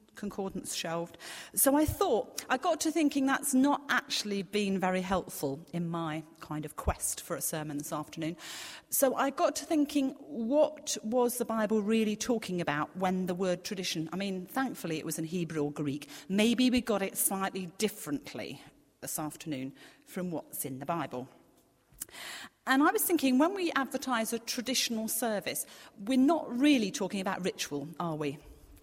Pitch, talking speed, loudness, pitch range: 195 Hz, 170 wpm, -31 LUFS, 160-260 Hz